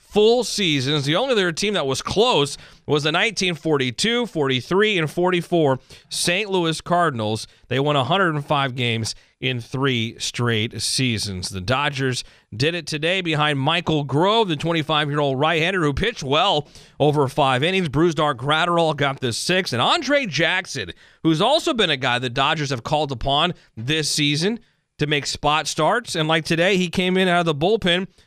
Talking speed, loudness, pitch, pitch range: 165 wpm, -20 LUFS, 155 Hz, 135-175 Hz